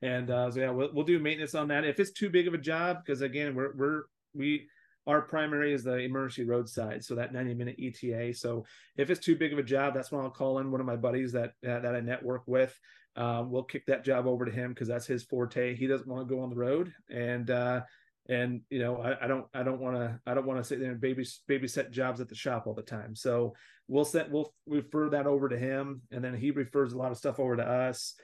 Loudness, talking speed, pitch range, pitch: -32 LUFS, 260 wpm, 125-140 Hz, 130 Hz